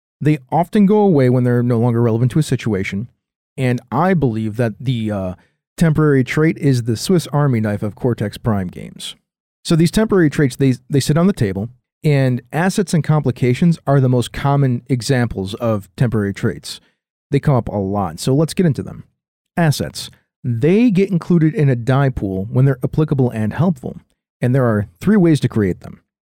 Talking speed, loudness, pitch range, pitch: 190 wpm, -17 LUFS, 115-155 Hz, 130 Hz